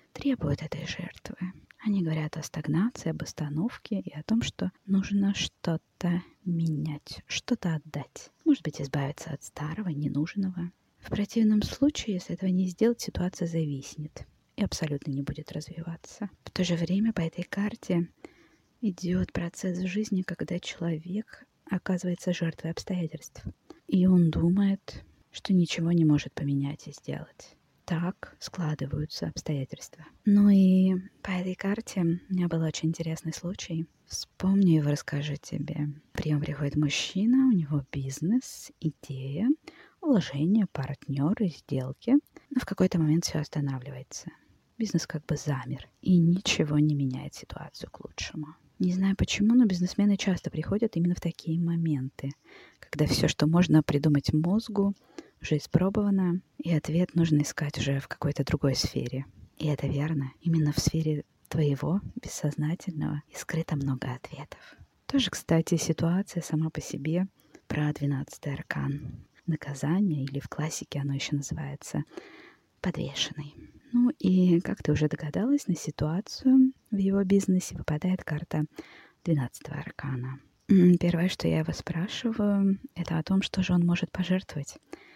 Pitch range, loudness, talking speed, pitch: 150-190 Hz, -29 LUFS, 135 wpm, 165 Hz